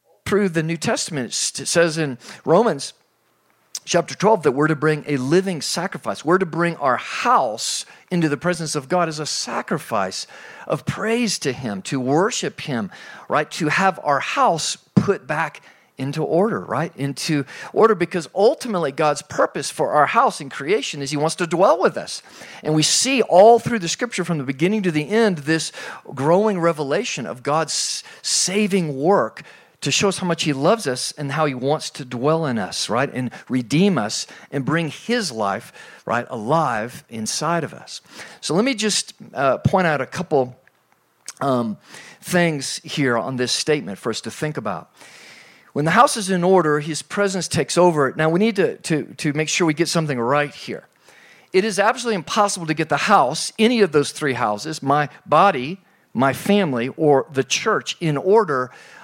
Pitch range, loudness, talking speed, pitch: 145-195 Hz, -20 LUFS, 180 wpm, 160 Hz